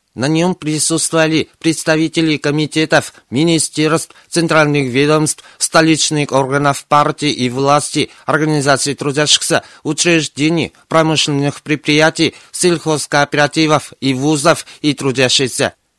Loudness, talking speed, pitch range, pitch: -14 LUFS, 85 wpm, 140-160 Hz, 150 Hz